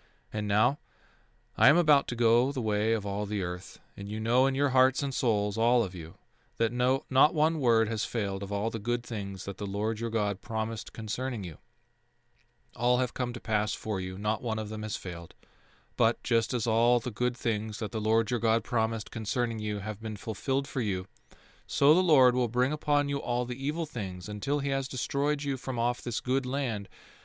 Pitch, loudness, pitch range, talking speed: 115 Hz, -29 LUFS, 110-125 Hz, 215 wpm